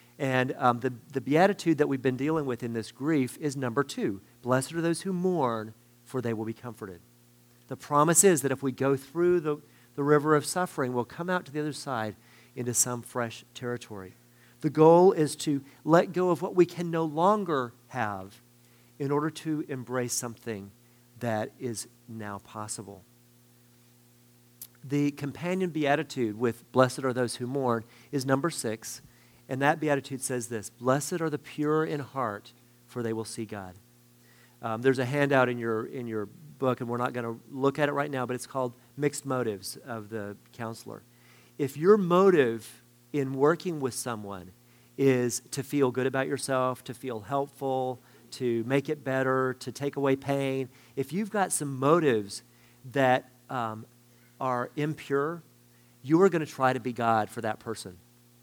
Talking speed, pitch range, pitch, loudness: 175 wpm, 120-145 Hz, 125 Hz, -28 LUFS